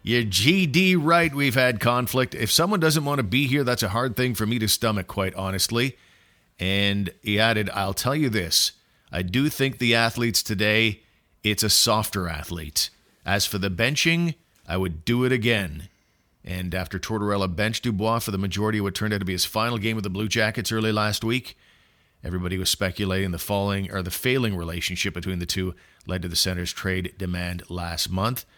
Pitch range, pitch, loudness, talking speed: 95-120 Hz, 105 Hz, -23 LUFS, 195 wpm